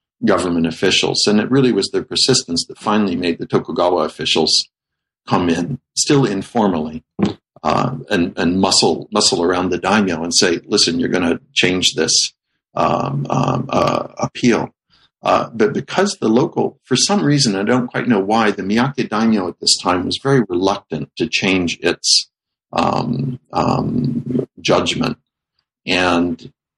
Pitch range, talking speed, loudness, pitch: 85-125 Hz, 150 wpm, -16 LUFS, 95 Hz